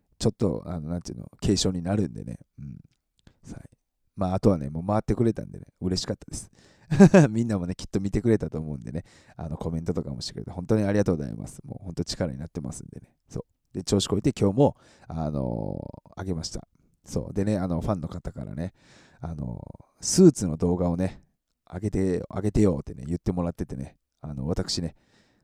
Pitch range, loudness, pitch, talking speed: 85-105 Hz, -26 LUFS, 95 Hz, 415 characters per minute